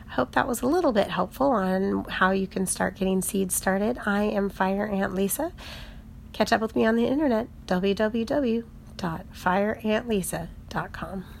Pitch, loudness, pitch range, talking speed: 205 Hz, -26 LUFS, 190-230 Hz, 155 wpm